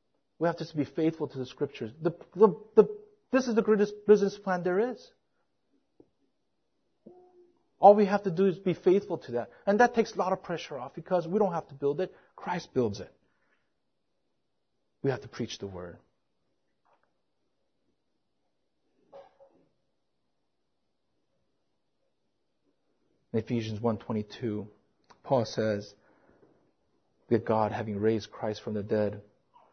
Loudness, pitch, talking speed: -29 LUFS, 160 Hz, 135 wpm